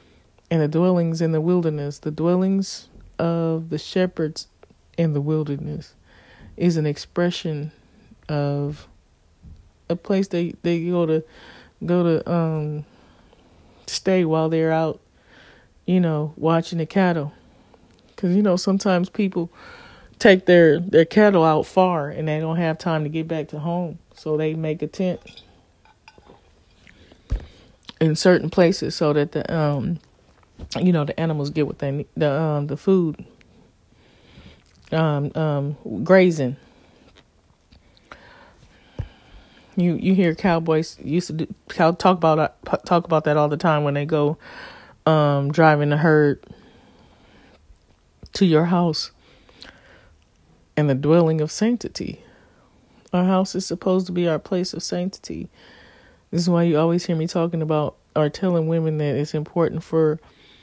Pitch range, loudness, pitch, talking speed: 150-175 Hz, -21 LUFS, 160 Hz, 140 wpm